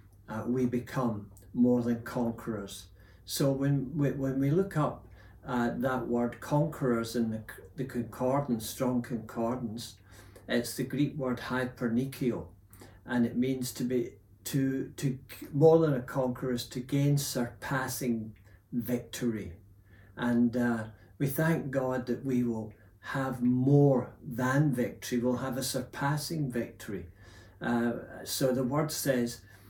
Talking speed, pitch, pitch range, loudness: 130 wpm, 120 Hz, 110-130 Hz, -31 LUFS